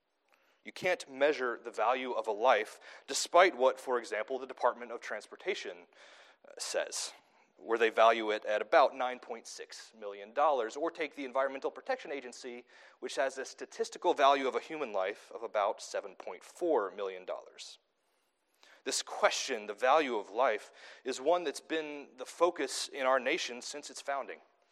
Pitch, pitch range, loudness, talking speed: 135 Hz, 120-170 Hz, -33 LUFS, 150 wpm